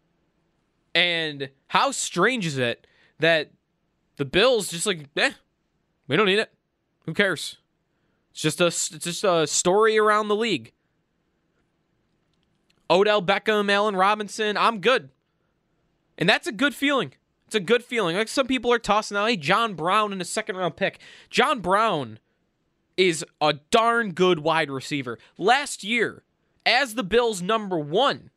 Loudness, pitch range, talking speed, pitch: -22 LUFS, 165-215 Hz, 150 wpm, 185 Hz